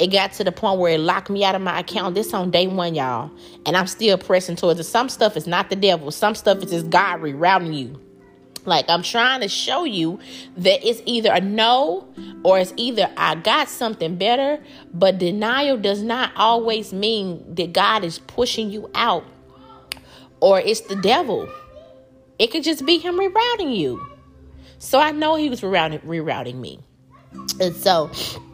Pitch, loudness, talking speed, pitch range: 190 Hz, -19 LUFS, 185 wpm, 170-230 Hz